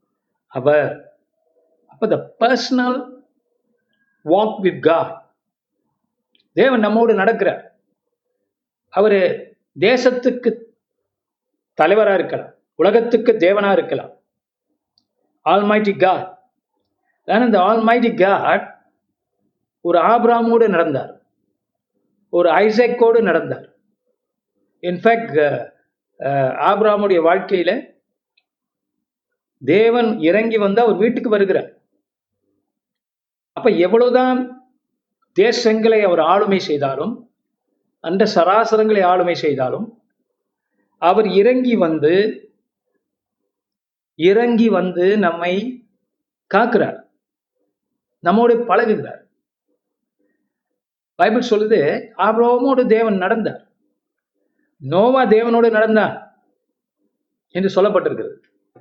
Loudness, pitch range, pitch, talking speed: -16 LUFS, 185-245 Hz, 225 Hz, 60 wpm